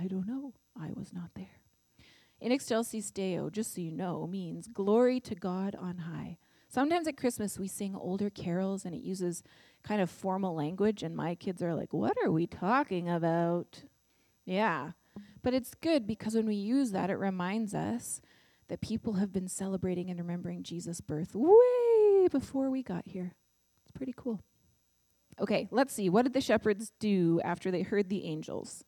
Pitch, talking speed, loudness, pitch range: 195 Hz, 180 wpm, -32 LUFS, 180-230 Hz